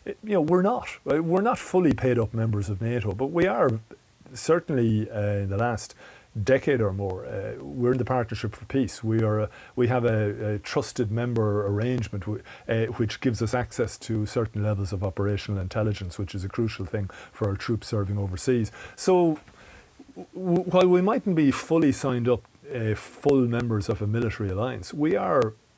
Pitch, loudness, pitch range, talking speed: 115 Hz, -26 LUFS, 105-130 Hz, 185 wpm